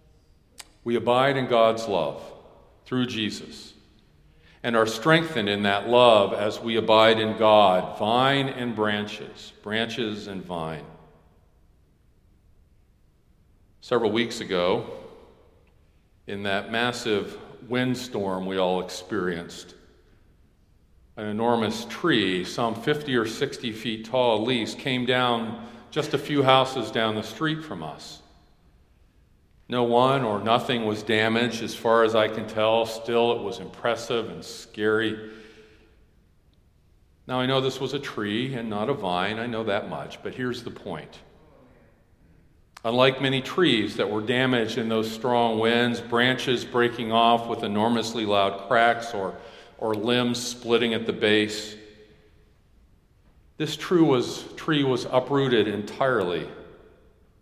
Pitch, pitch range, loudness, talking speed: 110 Hz, 95-120 Hz, -24 LUFS, 130 wpm